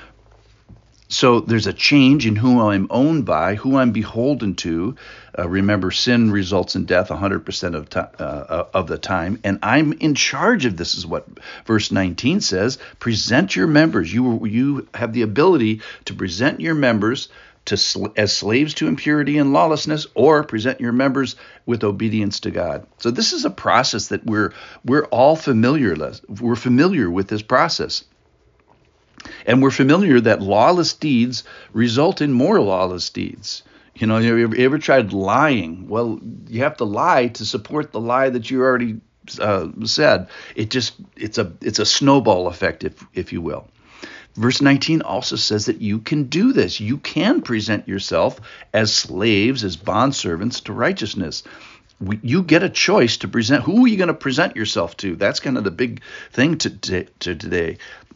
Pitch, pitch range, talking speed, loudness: 115 Hz, 105-135 Hz, 175 wpm, -18 LUFS